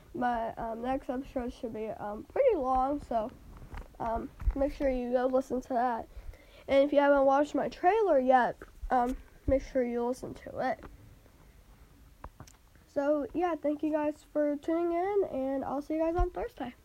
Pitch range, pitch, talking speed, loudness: 250-300 Hz, 270 Hz, 170 wpm, -31 LUFS